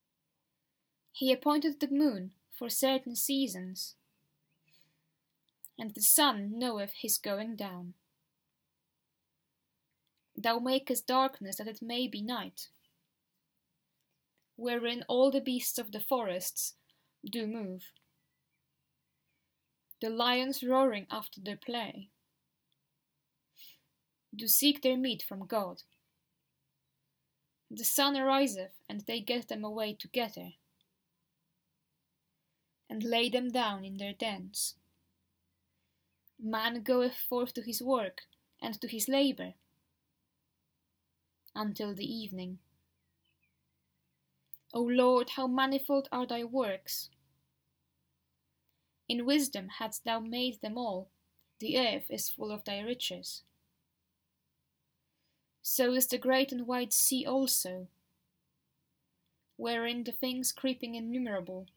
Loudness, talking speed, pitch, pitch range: -32 LUFS, 105 wpm, 220 Hz, 155-250 Hz